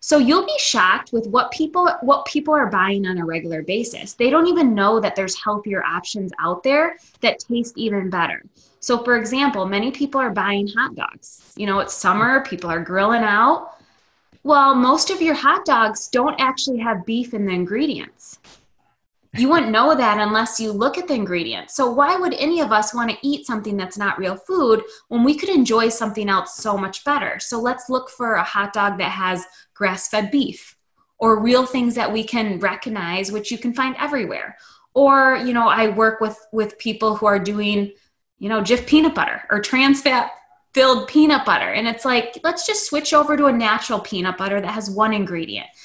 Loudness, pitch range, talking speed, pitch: -19 LUFS, 205-270 Hz, 200 wpm, 230 Hz